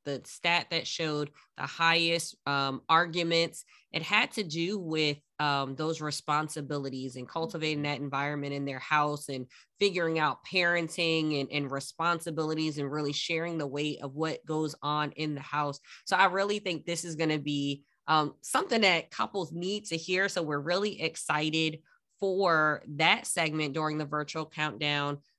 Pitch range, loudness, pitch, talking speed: 145-170 Hz, -30 LUFS, 155 Hz, 165 wpm